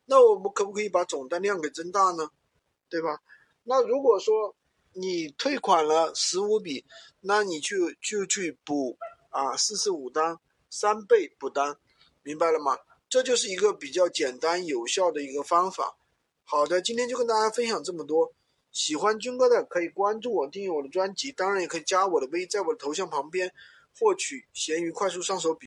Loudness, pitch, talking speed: -27 LUFS, 210 Hz, 275 characters per minute